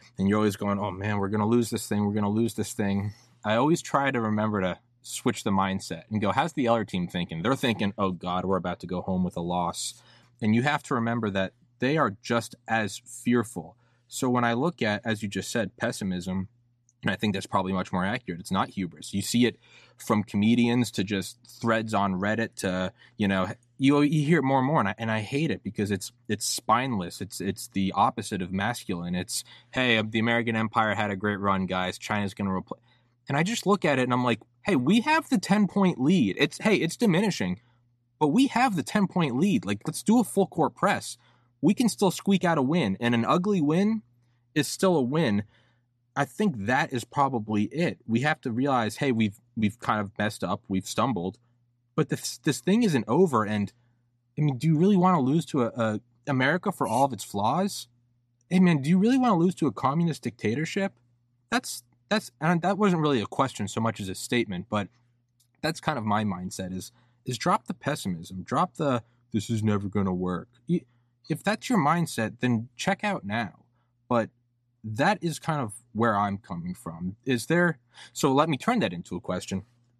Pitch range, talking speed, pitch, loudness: 105-145 Hz, 220 wpm, 120 Hz, -27 LUFS